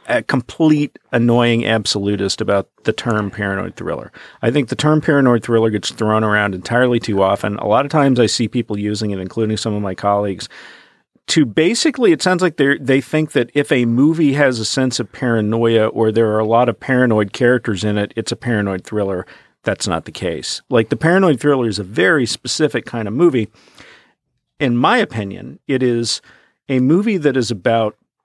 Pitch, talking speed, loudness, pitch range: 115 Hz, 195 wpm, -16 LUFS, 105-135 Hz